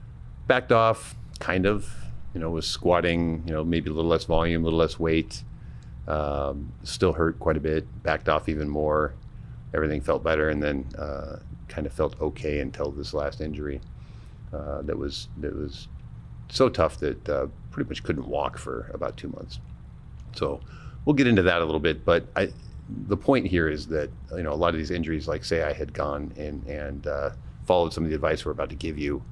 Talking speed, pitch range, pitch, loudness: 205 wpm, 70-80 Hz, 75 Hz, -27 LUFS